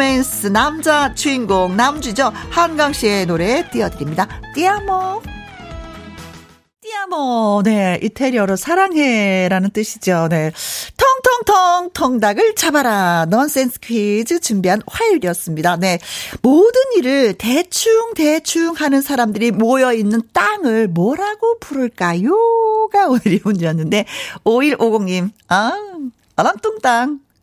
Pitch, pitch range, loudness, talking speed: 255 Hz, 210-340 Hz, -15 LUFS, 245 characters per minute